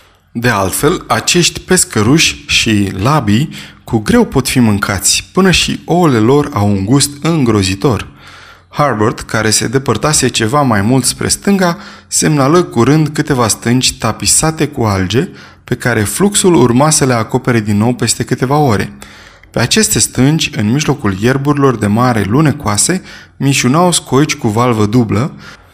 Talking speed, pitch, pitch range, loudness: 140 wpm, 125 Hz, 110-150 Hz, -11 LUFS